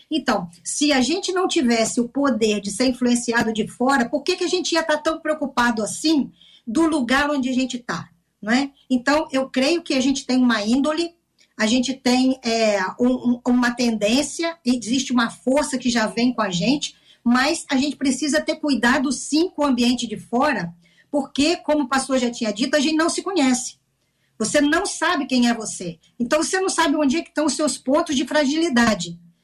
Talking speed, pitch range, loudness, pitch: 200 wpm, 235-300 Hz, -20 LUFS, 265 Hz